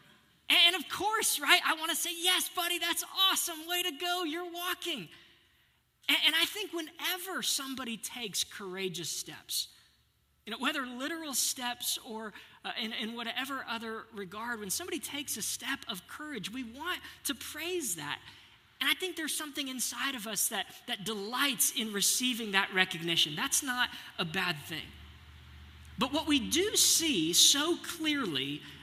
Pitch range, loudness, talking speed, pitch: 220-335 Hz, -30 LUFS, 160 wpm, 275 Hz